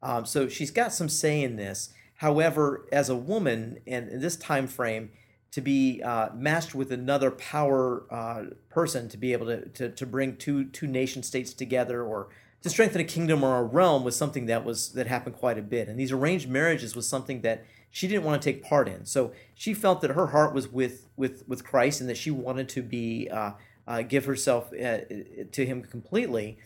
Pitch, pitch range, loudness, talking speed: 130 Hz, 120-145 Hz, -28 LUFS, 210 wpm